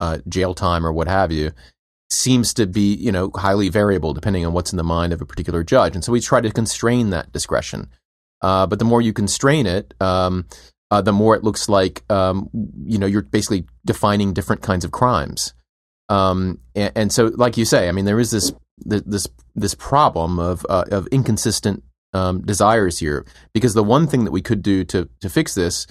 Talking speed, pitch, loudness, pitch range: 210 wpm, 95 Hz, -19 LUFS, 85-110 Hz